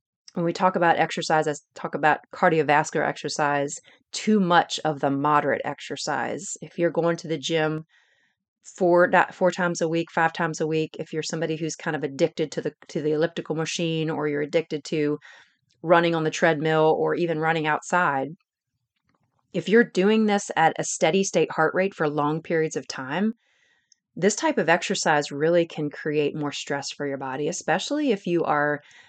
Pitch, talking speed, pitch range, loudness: 160 Hz, 180 wpm, 150-175 Hz, -24 LUFS